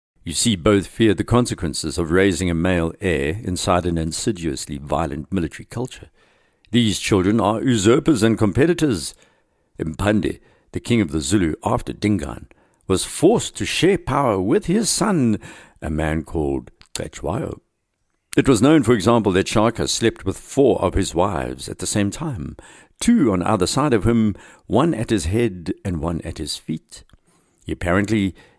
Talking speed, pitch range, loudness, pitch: 160 wpm, 85-115 Hz, -20 LUFS, 95 Hz